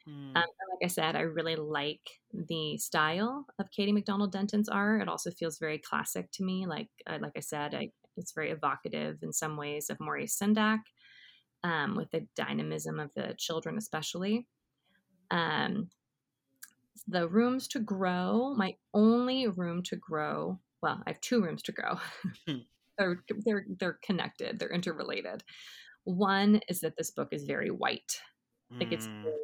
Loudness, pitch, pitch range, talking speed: -33 LUFS, 180 Hz, 155-210 Hz, 160 wpm